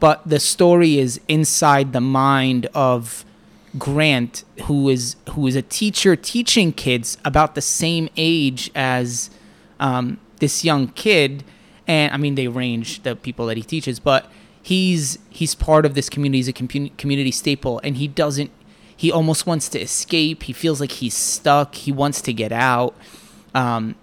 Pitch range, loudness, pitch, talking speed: 130-155 Hz, -19 LUFS, 140 Hz, 165 wpm